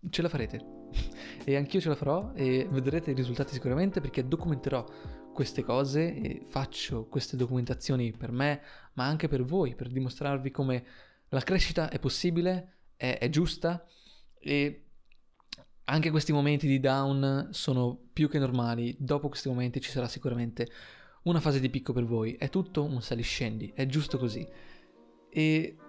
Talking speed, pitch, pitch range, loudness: 160 wpm, 135 Hz, 125-155 Hz, -31 LUFS